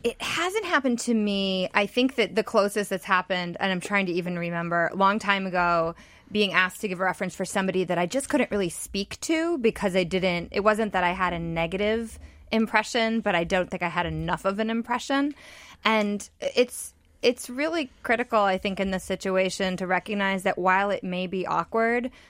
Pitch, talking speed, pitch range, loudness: 200 Hz, 205 wpm, 185-225 Hz, -25 LUFS